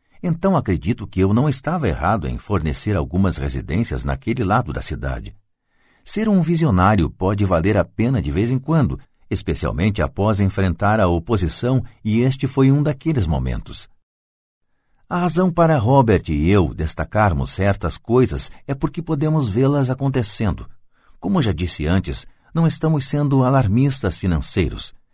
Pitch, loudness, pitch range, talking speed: 105 Hz, -19 LUFS, 85-135 Hz, 145 wpm